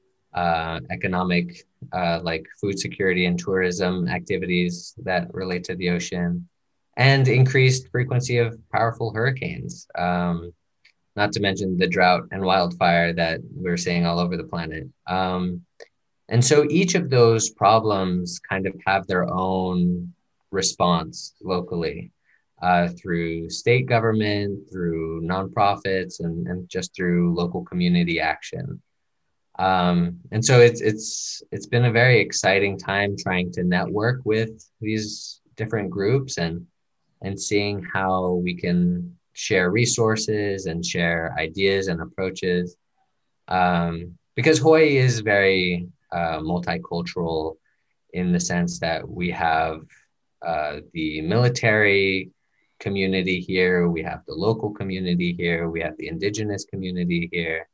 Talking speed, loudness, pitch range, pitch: 130 wpm, -22 LUFS, 90-110 Hz, 95 Hz